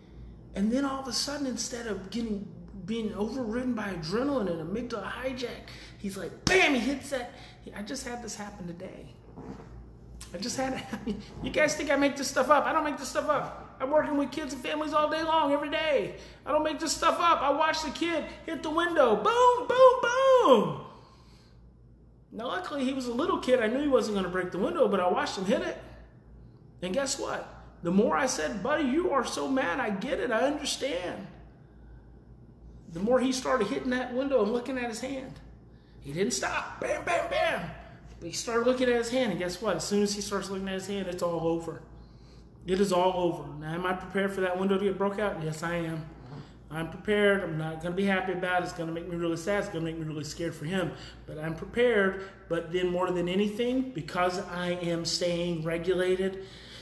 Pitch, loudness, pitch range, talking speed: 210 Hz, -29 LUFS, 180-270 Hz, 220 wpm